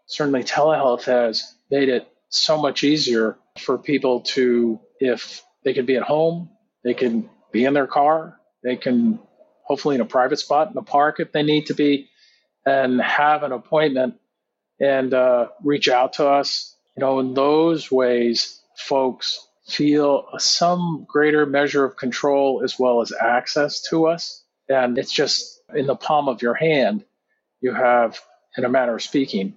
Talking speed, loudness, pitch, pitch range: 165 wpm, -20 LUFS, 140 Hz, 125-155 Hz